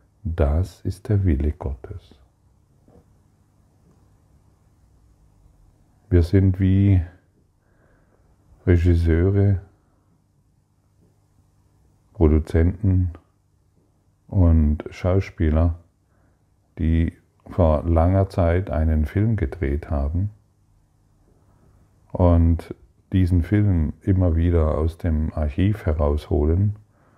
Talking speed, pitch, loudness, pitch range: 65 wpm, 95 Hz, -21 LUFS, 85-100 Hz